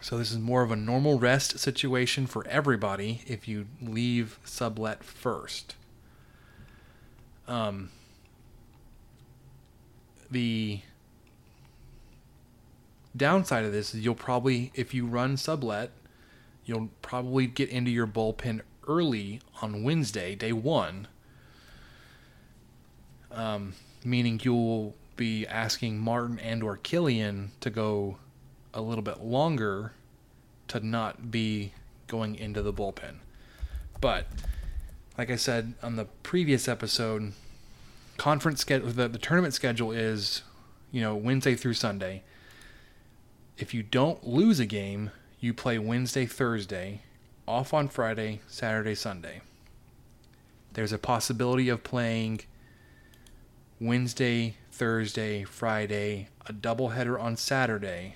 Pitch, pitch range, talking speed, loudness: 115 Hz, 110-125 Hz, 110 wpm, -30 LUFS